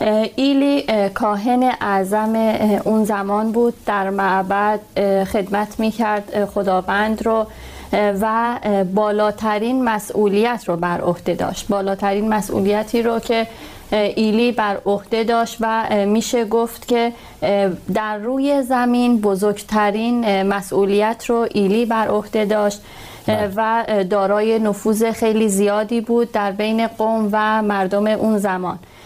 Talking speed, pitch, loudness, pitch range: 115 wpm, 215 Hz, -18 LUFS, 200-225 Hz